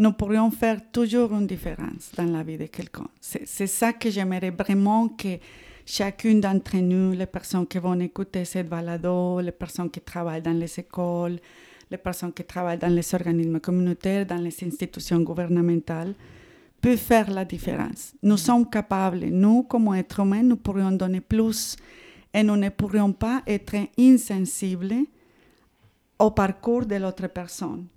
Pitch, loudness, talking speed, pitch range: 190 Hz, -24 LUFS, 160 wpm, 175-210 Hz